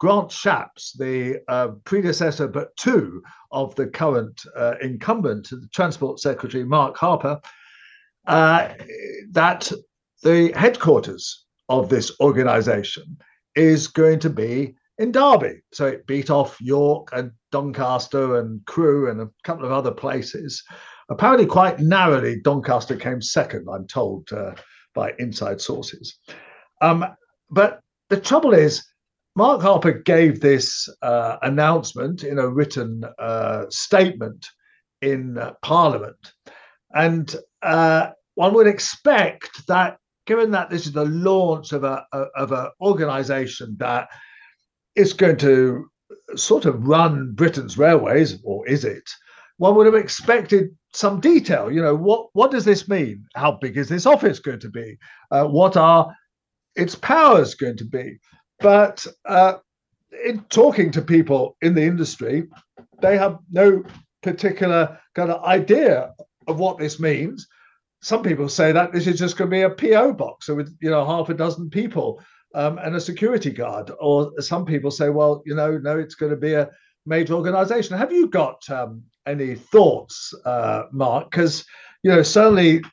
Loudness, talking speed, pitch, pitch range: -19 LUFS, 150 wpm, 160 Hz, 140-190 Hz